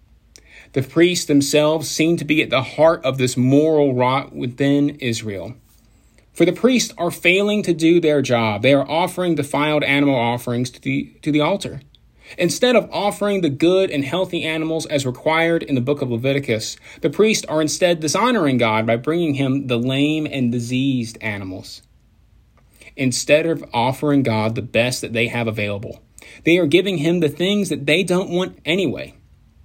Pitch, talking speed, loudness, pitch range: 145 Hz, 170 wpm, -18 LUFS, 125-165 Hz